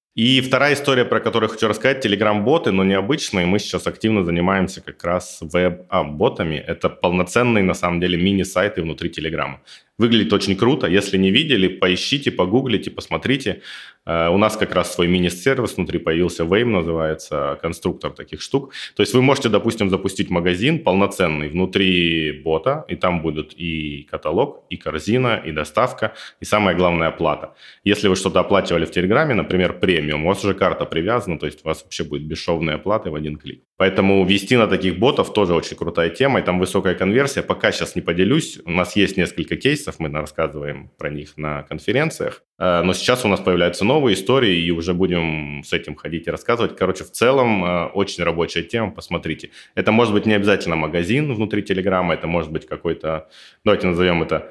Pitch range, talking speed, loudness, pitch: 80-100 Hz, 175 wpm, -19 LUFS, 90 Hz